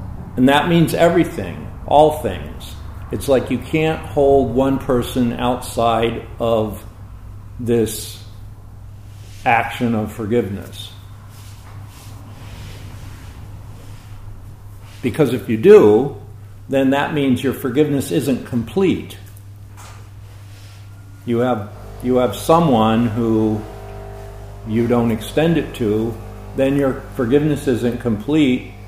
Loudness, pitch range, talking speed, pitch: -17 LUFS, 100-125 Hz, 95 wpm, 110 Hz